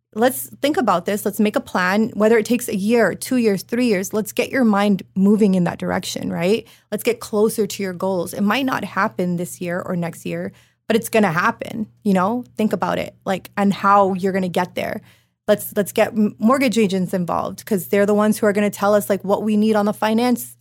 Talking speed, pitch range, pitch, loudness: 240 wpm, 195-220 Hz, 210 Hz, -19 LUFS